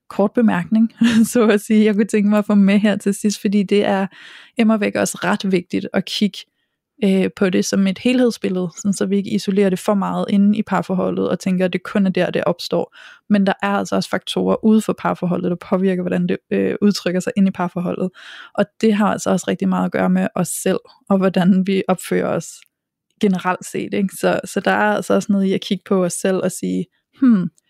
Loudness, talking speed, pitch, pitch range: -18 LUFS, 230 wpm, 195 Hz, 180-210 Hz